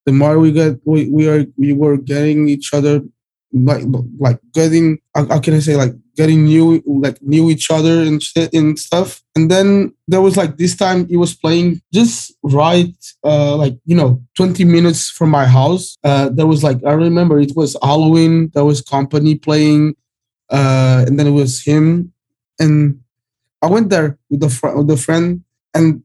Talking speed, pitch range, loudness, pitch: 185 wpm, 140-165 Hz, -13 LUFS, 150 Hz